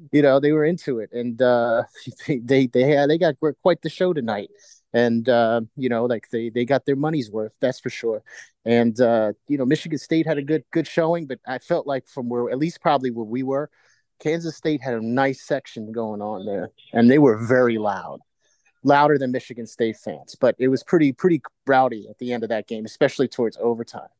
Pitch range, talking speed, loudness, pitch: 115-155 Hz, 220 wpm, -22 LUFS, 130 Hz